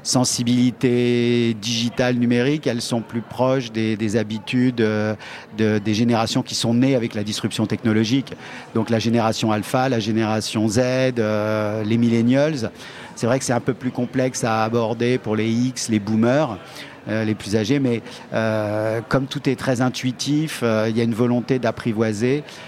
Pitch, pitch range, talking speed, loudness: 115 Hz, 110-125 Hz, 170 wpm, -21 LUFS